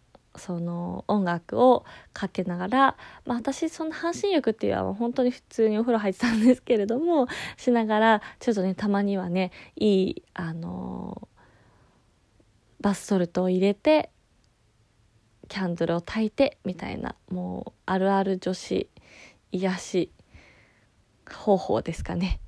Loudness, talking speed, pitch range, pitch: -26 LUFS, 270 characters per minute, 180-240 Hz, 195 Hz